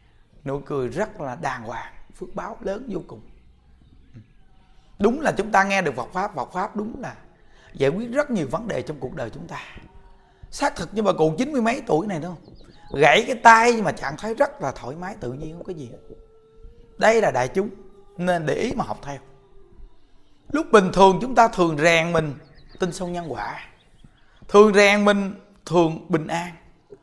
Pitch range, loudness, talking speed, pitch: 145-215 Hz, -21 LUFS, 200 wpm, 180 Hz